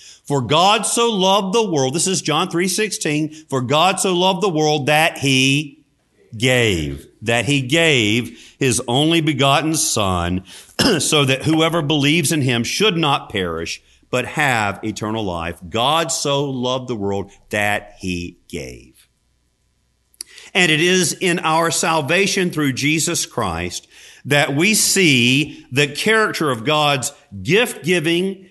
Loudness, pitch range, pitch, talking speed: -17 LUFS, 115-165 Hz, 145 Hz, 140 wpm